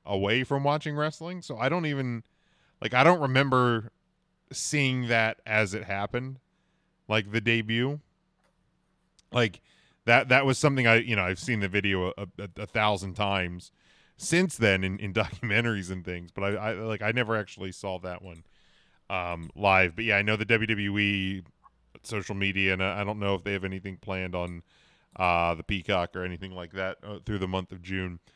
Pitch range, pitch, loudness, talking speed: 95-120 Hz, 105 Hz, -27 LUFS, 185 wpm